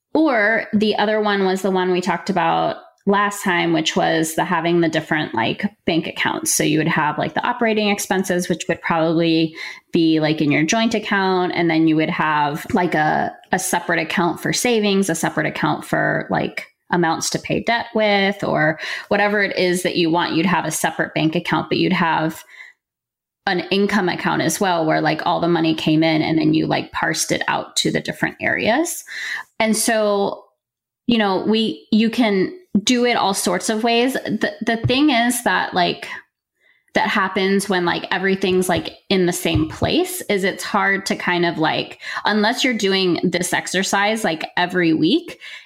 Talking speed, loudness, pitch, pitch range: 190 wpm, -19 LUFS, 190 Hz, 170-215 Hz